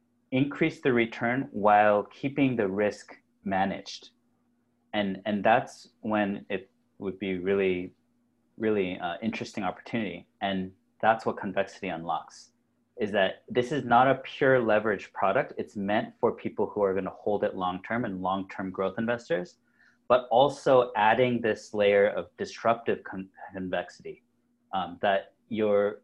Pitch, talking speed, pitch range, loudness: 110 Hz, 145 wpm, 100-120 Hz, -28 LUFS